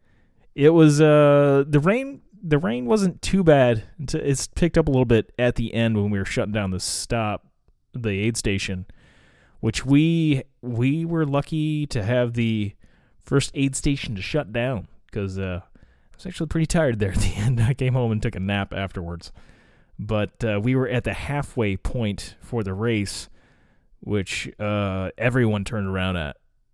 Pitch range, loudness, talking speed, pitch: 100-145 Hz, -22 LUFS, 175 wpm, 120 Hz